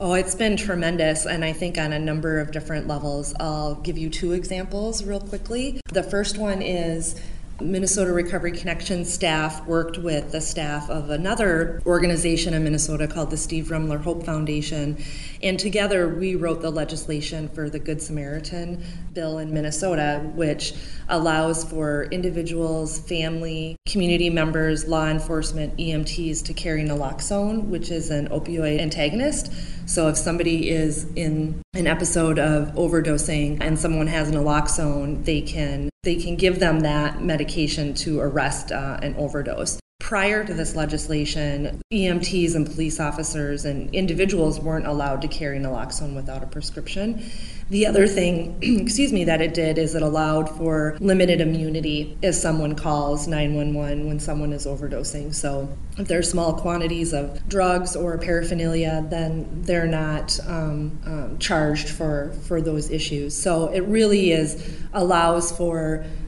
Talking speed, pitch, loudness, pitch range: 150 wpm, 160 Hz, -24 LUFS, 150-175 Hz